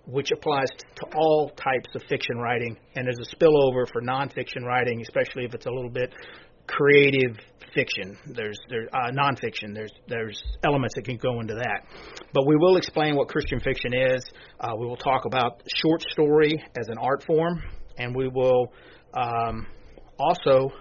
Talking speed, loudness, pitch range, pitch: 170 wpm, -25 LUFS, 120-145 Hz, 130 Hz